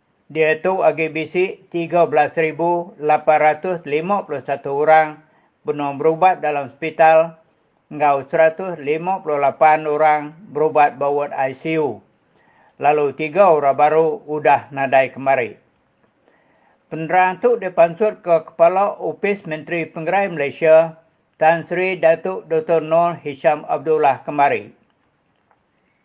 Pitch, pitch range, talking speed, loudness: 160 Hz, 150-170 Hz, 90 wpm, -17 LUFS